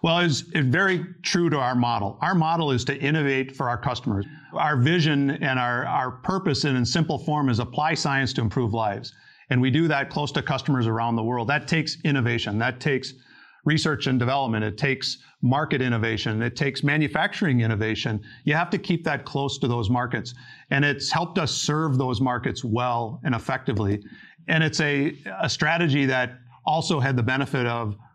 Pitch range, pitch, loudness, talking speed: 120-155 Hz, 135 Hz, -24 LUFS, 185 wpm